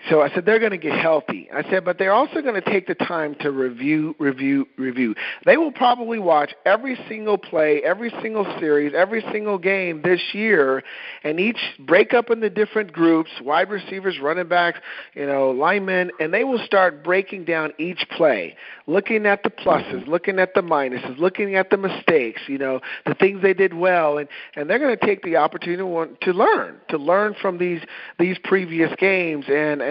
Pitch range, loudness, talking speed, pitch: 150-205 Hz, -20 LUFS, 200 wpm, 180 Hz